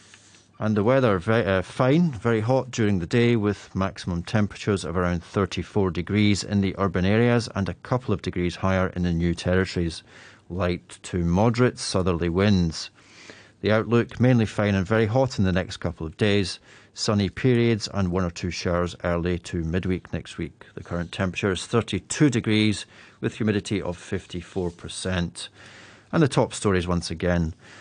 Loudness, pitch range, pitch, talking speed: -24 LUFS, 90-110 Hz, 100 Hz, 175 wpm